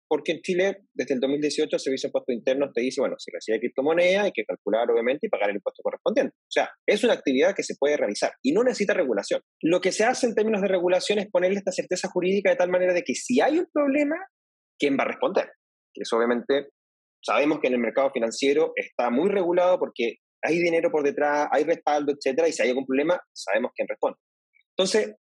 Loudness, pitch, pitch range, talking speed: -24 LUFS, 180 Hz, 140-215 Hz, 220 wpm